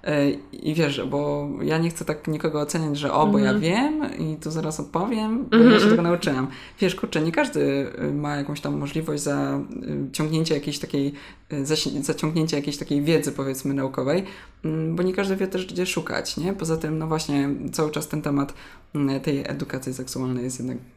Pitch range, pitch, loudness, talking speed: 140-170 Hz, 155 Hz, -24 LUFS, 170 wpm